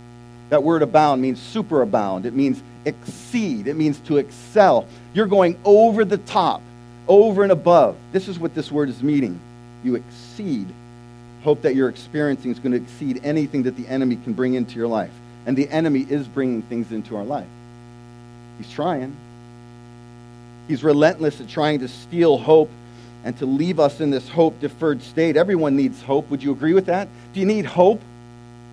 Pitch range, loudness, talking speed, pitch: 120-155 Hz, -20 LUFS, 180 wpm, 135 Hz